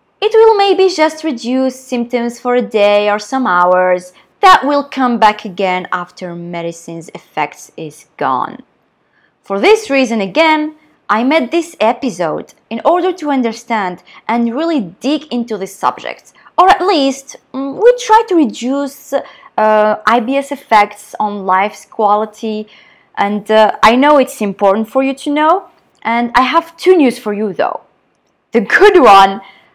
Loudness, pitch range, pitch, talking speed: -12 LUFS, 205-295 Hz, 240 Hz, 150 wpm